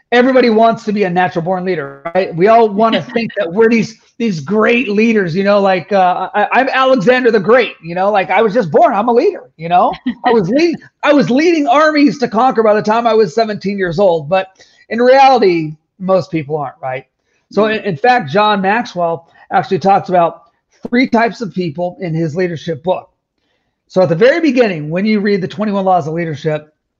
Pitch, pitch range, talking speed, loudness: 205 Hz, 180-230 Hz, 210 wpm, -13 LUFS